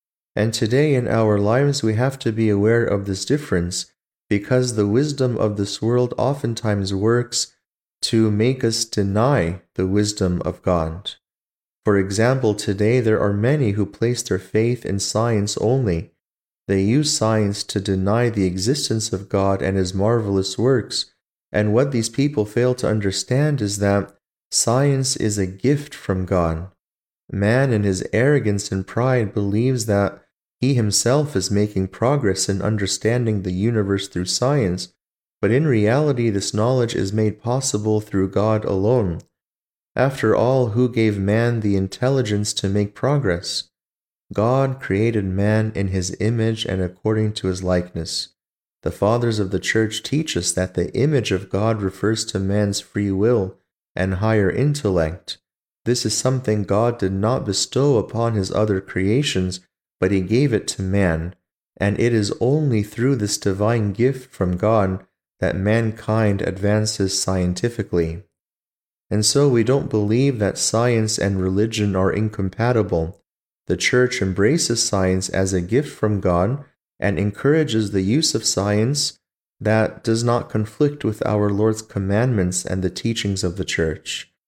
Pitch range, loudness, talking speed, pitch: 95-120 Hz, -20 LUFS, 150 wpm, 105 Hz